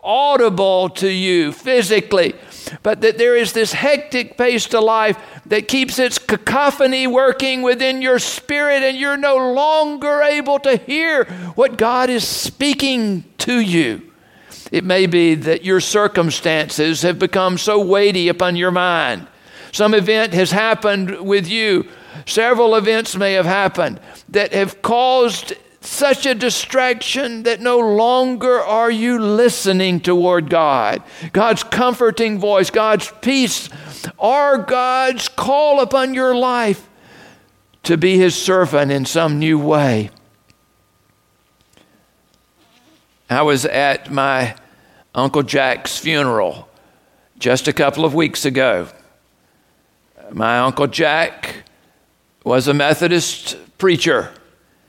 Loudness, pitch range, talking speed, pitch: -16 LUFS, 170-250 Hz, 120 wpm, 210 Hz